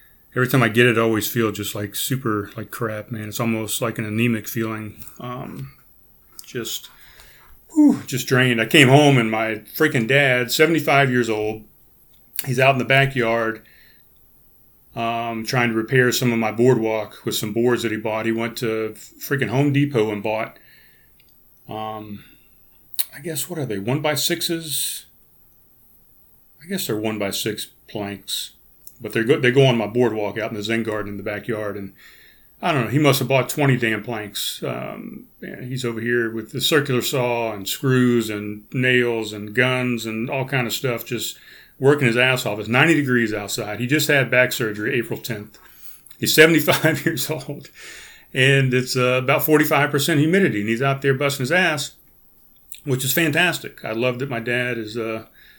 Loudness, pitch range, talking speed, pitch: -20 LUFS, 110-135 Hz, 185 wpm, 120 Hz